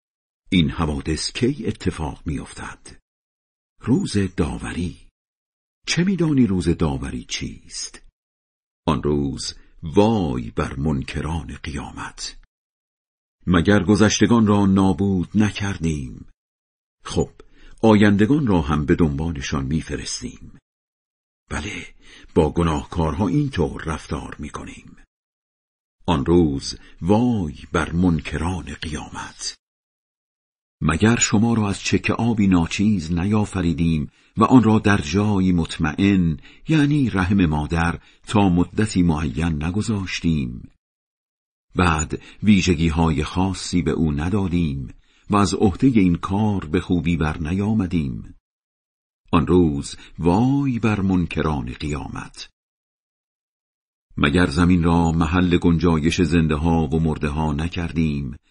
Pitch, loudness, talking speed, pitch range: 90 Hz, -20 LUFS, 105 wpm, 80-100 Hz